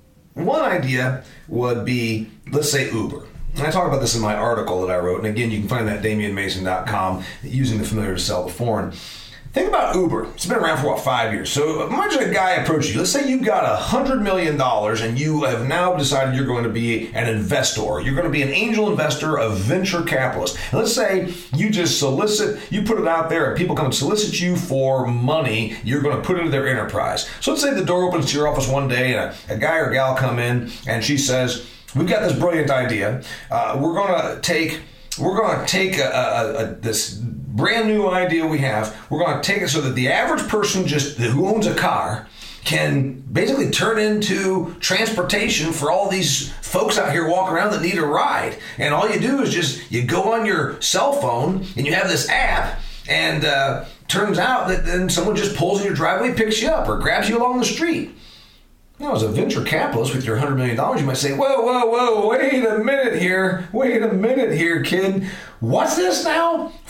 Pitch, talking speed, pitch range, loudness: 145 Hz, 220 wpm, 120-190 Hz, -20 LUFS